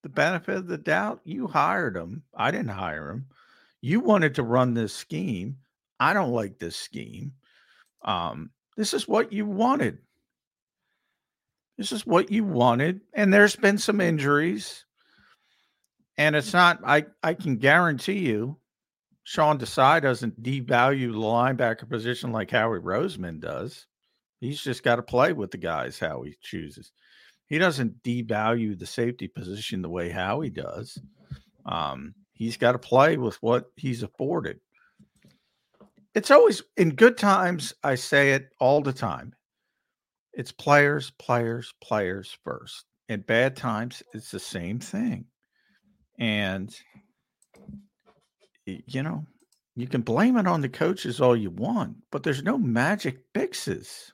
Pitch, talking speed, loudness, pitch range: 130 Hz, 145 wpm, -24 LUFS, 115-170 Hz